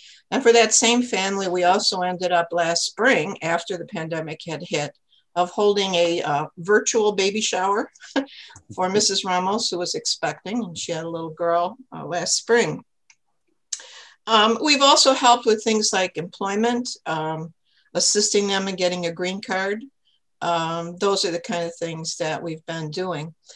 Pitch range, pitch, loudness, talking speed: 170-215 Hz, 185 Hz, -21 LUFS, 165 wpm